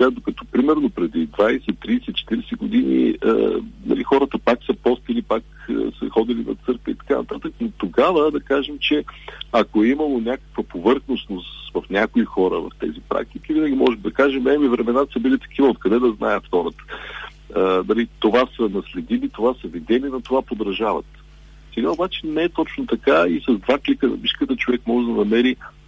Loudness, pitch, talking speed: -20 LUFS, 135 Hz, 180 wpm